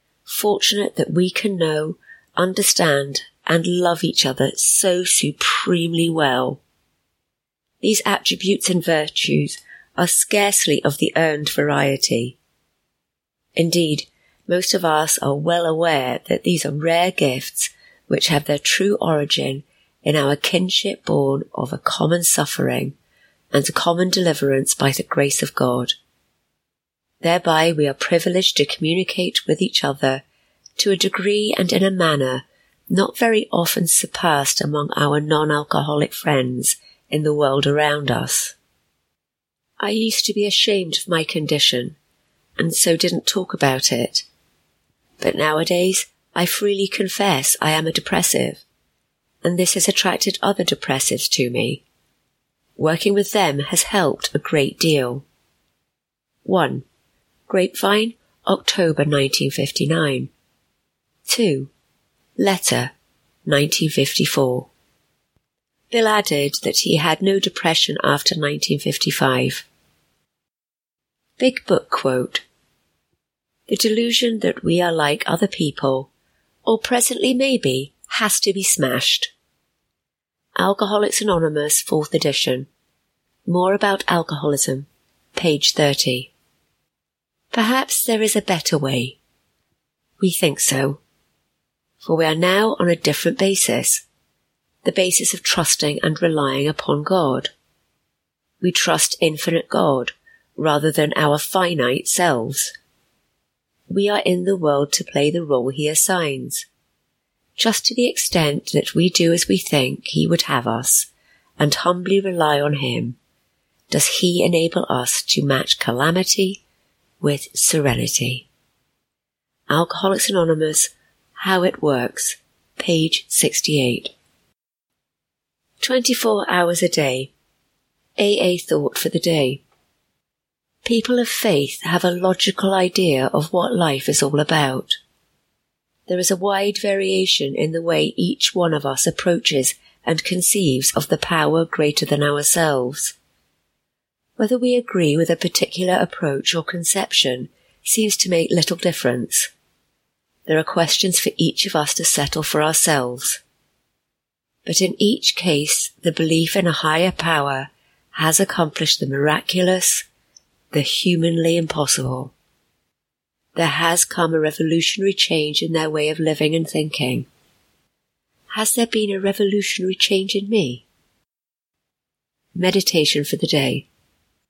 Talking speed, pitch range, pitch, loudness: 125 wpm, 145-195 Hz, 170 Hz, -18 LUFS